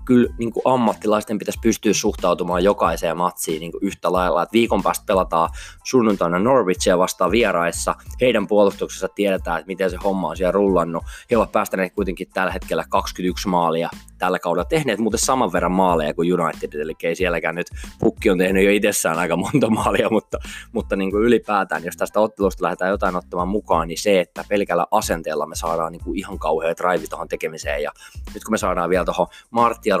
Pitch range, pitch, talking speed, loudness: 85-105 Hz, 95 Hz, 190 wpm, -20 LUFS